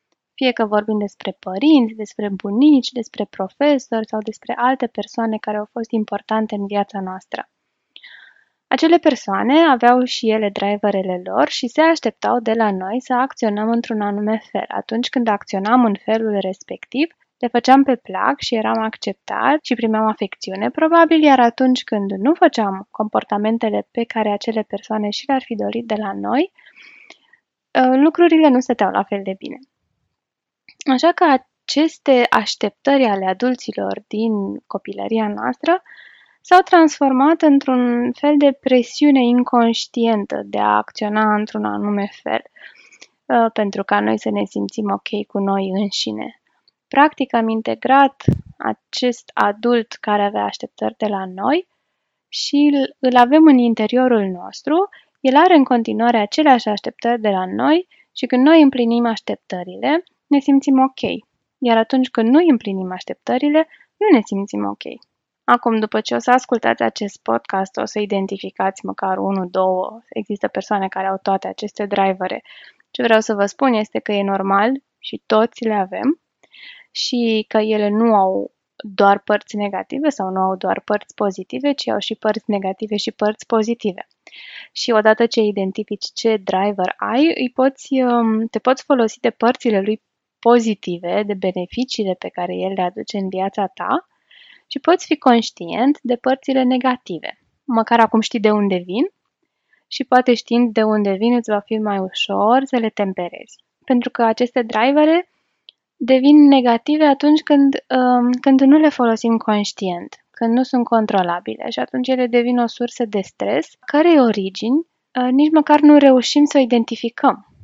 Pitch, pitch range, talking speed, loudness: 230 Hz, 205-265 Hz, 155 wpm, -17 LUFS